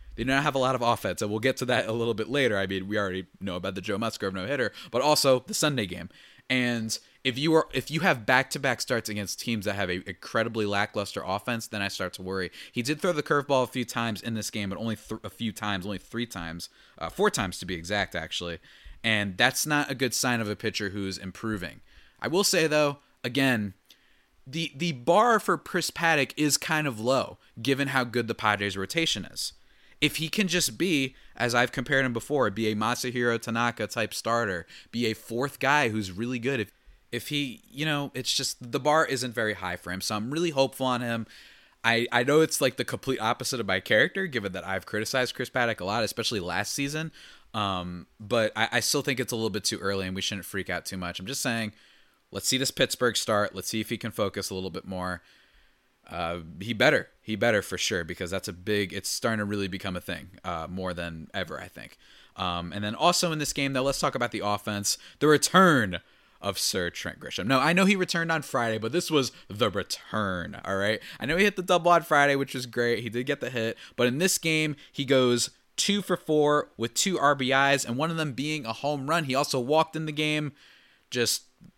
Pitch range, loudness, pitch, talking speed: 105-140 Hz, -27 LUFS, 120 Hz, 235 wpm